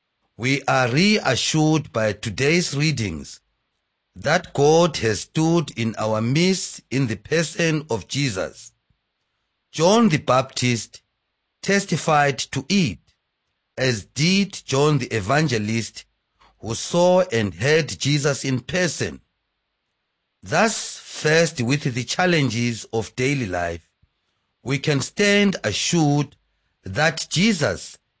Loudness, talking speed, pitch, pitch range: -21 LUFS, 105 wpm, 135 Hz, 115-160 Hz